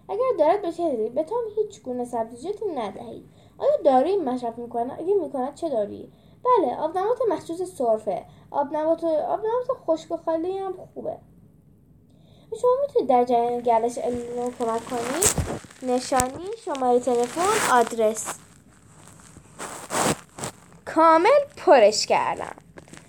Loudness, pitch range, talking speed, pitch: -23 LUFS, 245-380 Hz, 115 wpm, 305 Hz